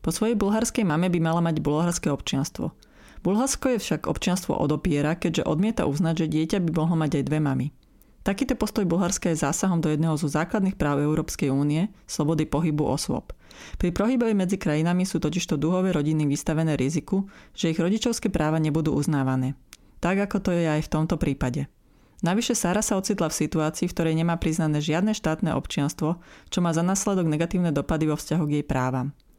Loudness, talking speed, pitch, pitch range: -25 LUFS, 180 wpm, 165 Hz, 155-190 Hz